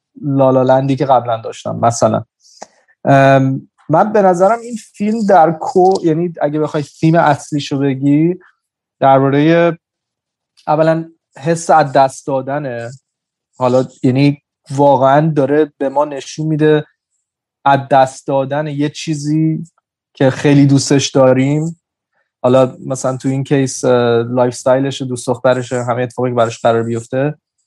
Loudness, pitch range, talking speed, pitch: -14 LUFS, 130-155 Hz, 120 wpm, 140 Hz